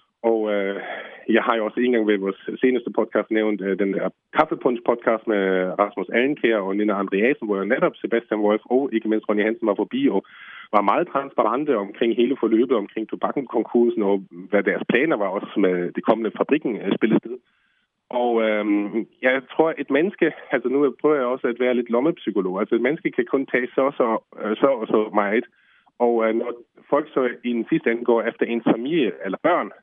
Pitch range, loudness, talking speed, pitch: 105-120 Hz, -22 LUFS, 200 wpm, 110 Hz